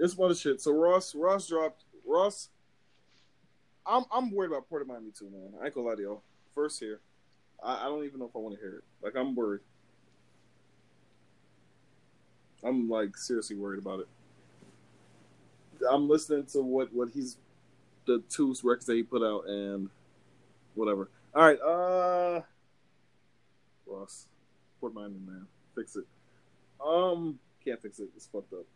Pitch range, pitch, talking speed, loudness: 105-160 Hz, 125 Hz, 165 wpm, -31 LUFS